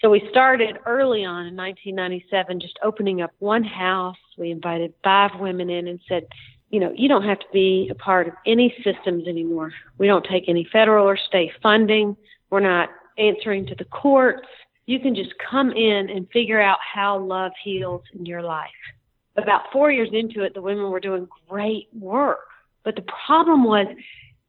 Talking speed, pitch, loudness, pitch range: 185 wpm, 195 Hz, -21 LUFS, 180-215 Hz